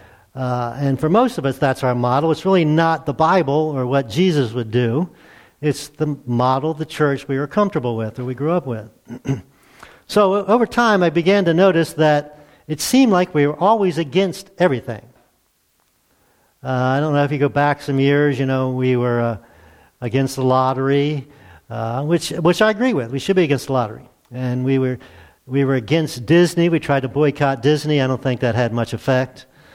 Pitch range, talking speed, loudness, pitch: 125-160 Hz, 200 wpm, -18 LUFS, 140 Hz